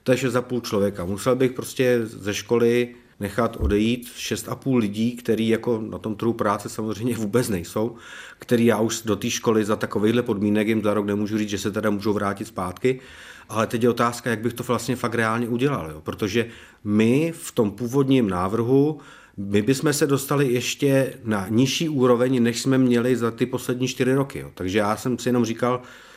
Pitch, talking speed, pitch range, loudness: 120 Hz, 190 wpm, 110-125 Hz, -23 LUFS